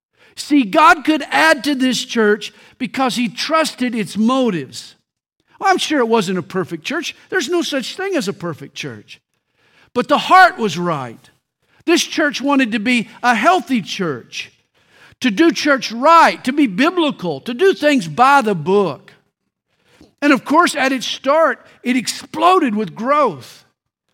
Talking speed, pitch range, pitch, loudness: 155 wpm, 230-315 Hz, 265 Hz, -16 LUFS